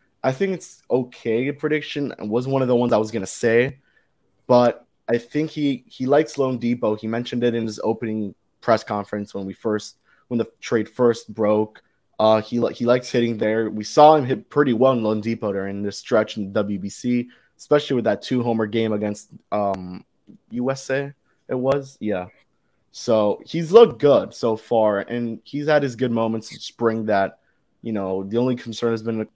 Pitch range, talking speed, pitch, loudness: 105-130 Hz, 190 wpm, 115 Hz, -21 LUFS